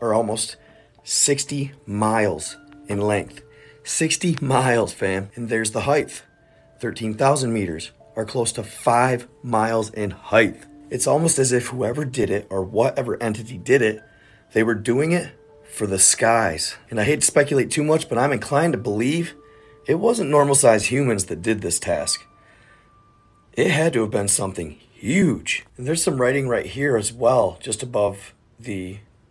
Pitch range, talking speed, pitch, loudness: 110-145 Hz, 165 wpm, 120 Hz, -21 LUFS